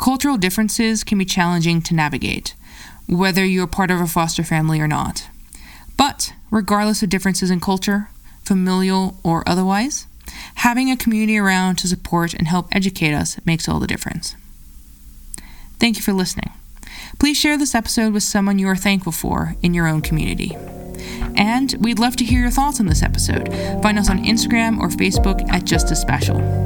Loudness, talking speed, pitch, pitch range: -18 LUFS, 170 wpm, 190 Hz, 170-220 Hz